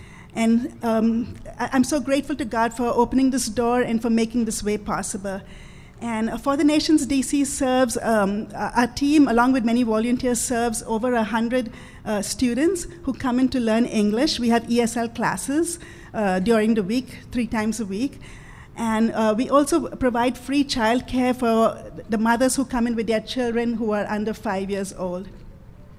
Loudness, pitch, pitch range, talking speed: -22 LUFS, 235 Hz, 220-260 Hz, 175 wpm